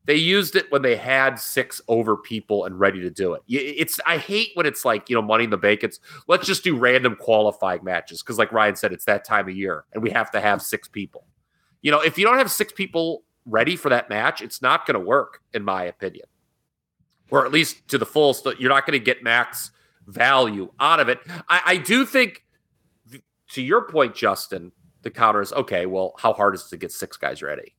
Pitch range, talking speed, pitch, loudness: 105-175 Hz, 225 wpm, 135 Hz, -21 LUFS